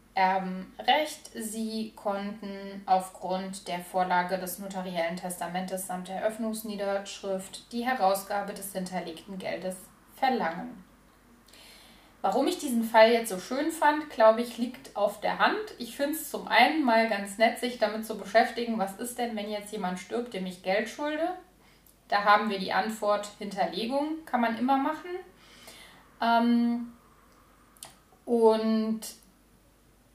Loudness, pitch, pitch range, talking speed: -28 LUFS, 215 Hz, 190-240 Hz, 130 wpm